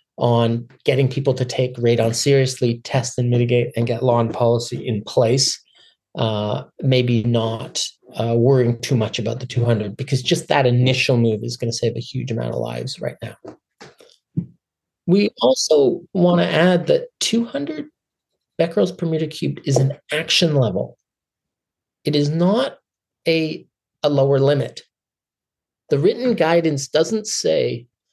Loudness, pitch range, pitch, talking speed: -19 LUFS, 120-165 Hz, 135 Hz, 150 wpm